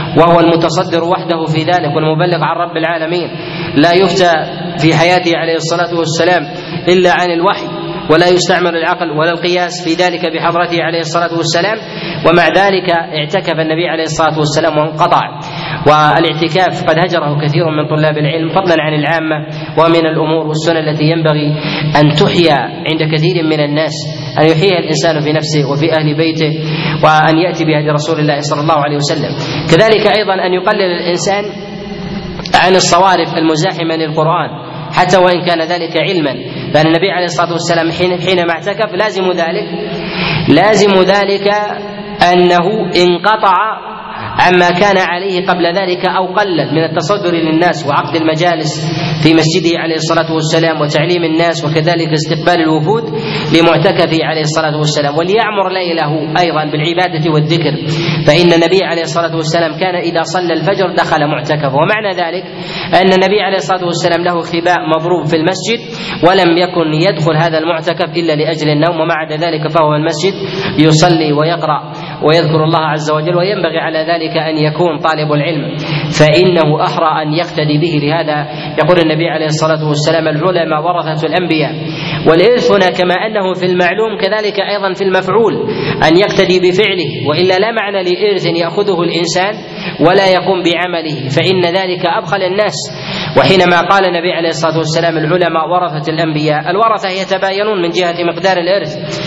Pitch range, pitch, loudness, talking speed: 155-180 Hz, 170 Hz, -11 LUFS, 145 wpm